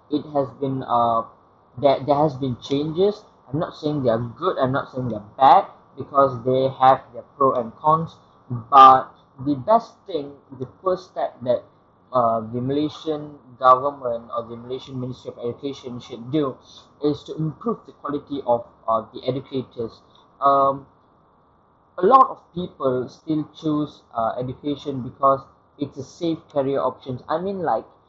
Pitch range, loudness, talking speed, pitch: 125-150 Hz, -21 LUFS, 160 wpm, 135 Hz